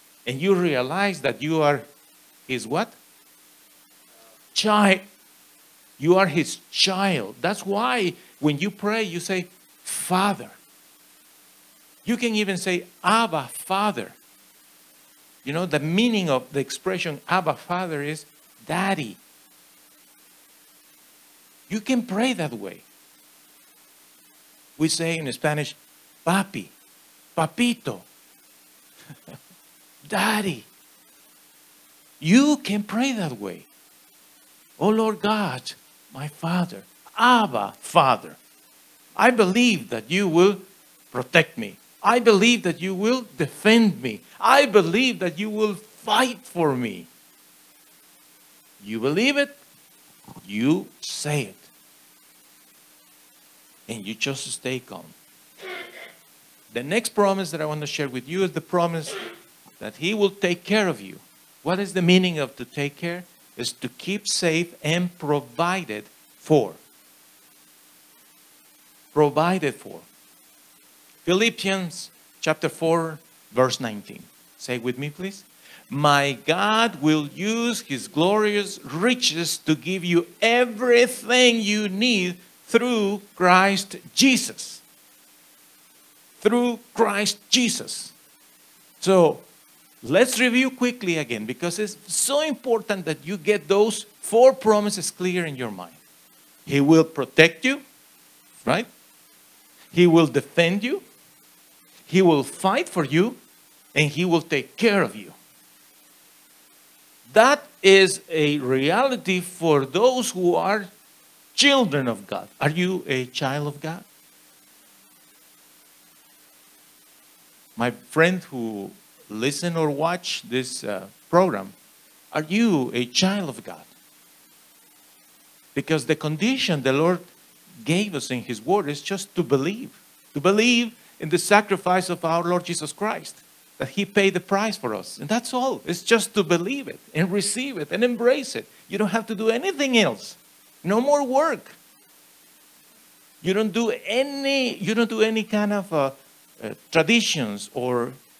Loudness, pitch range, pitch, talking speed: -22 LUFS, 150-215 Hz, 180 Hz, 120 wpm